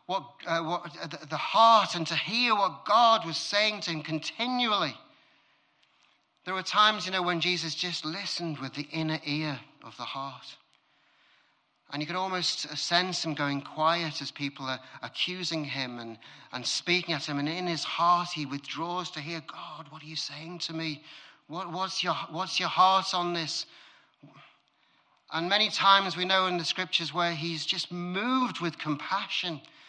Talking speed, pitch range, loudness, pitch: 175 wpm, 155-185 Hz, -28 LUFS, 170 Hz